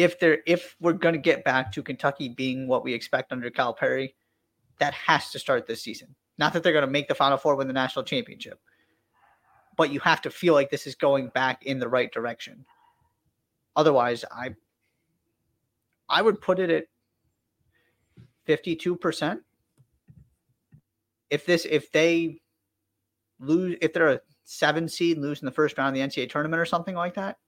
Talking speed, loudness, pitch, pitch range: 175 wpm, -25 LUFS, 145 Hz, 130-165 Hz